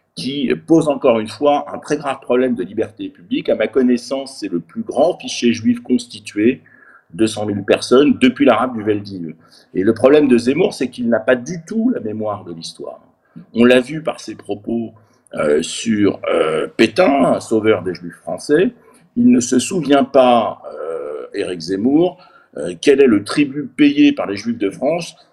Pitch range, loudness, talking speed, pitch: 110-160 Hz, -16 LUFS, 180 wpm, 125 Hz